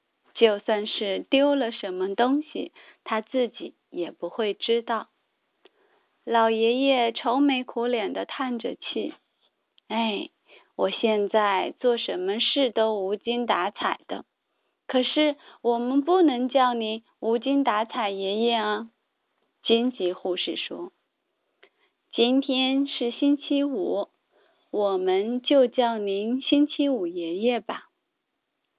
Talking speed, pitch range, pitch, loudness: 165 characters per minute, 215-270 Hz, 235 Hz, -25 LUFS